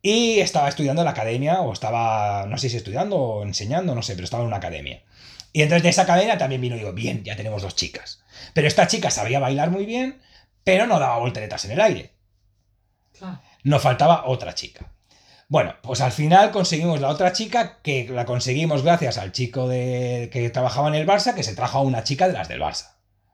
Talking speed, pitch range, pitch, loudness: 215 wpm, 110-170 Hz, 130 Hz, -21 LUFS